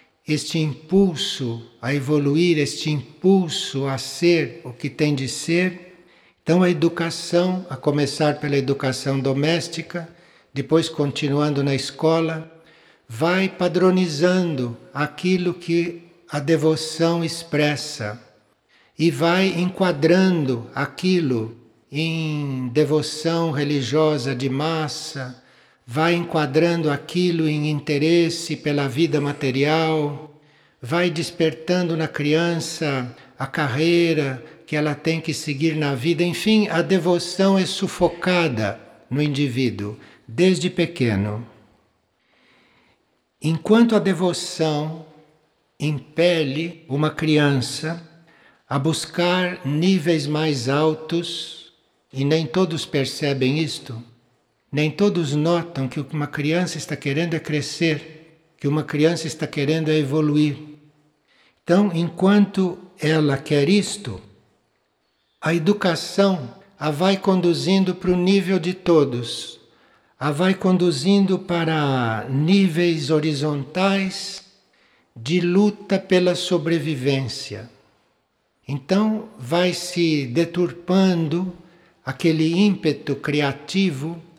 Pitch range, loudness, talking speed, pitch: 145-175 Hz, -21 LUFS, 95 wpm, 160 Hz